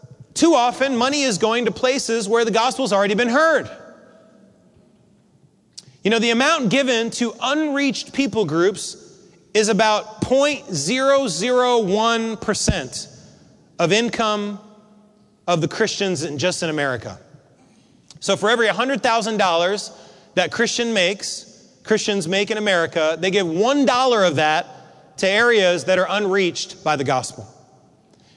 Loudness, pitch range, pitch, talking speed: -19 LUFS, 185-245 Hz, 215 Hz, 125 wpm